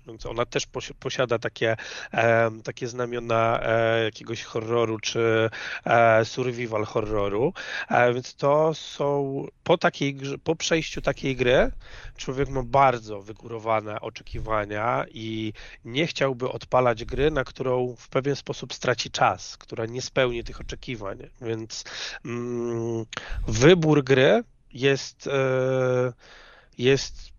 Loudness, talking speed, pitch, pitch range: -25 LUFS, 105 wpm, 125 Hz, 115-135 Hz